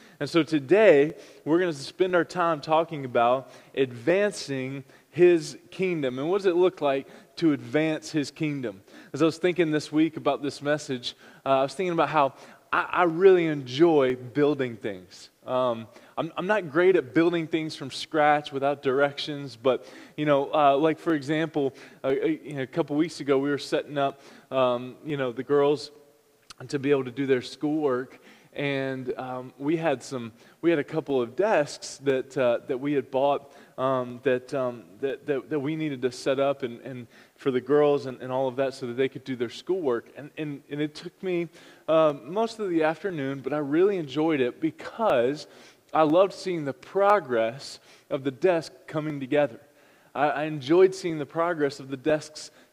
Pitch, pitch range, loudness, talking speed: 145 Hz, 135-160 Hz, -26 LUFS, 190 wpm